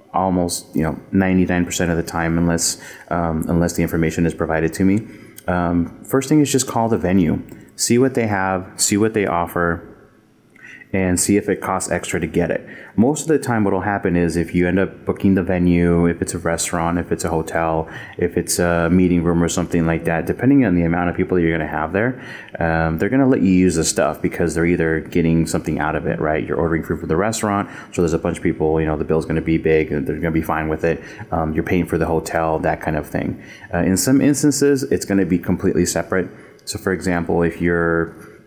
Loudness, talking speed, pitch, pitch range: -19 LUFS, 240 wpm, 85 Hz, 85-95 Hz